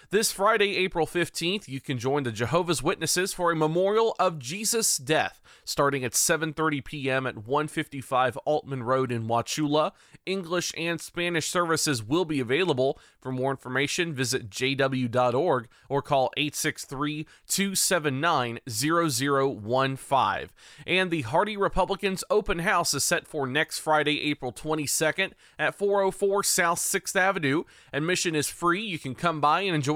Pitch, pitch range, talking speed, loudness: 155 Hz, 135-180 Hz, 135 wpm, -26 LUFS